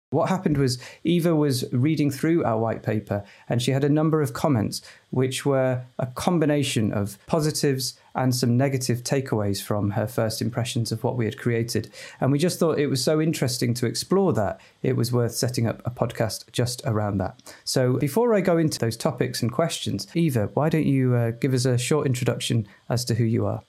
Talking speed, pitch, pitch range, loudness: 205 wpm, 130 Hz, 115-145 Hz, -24 LUFS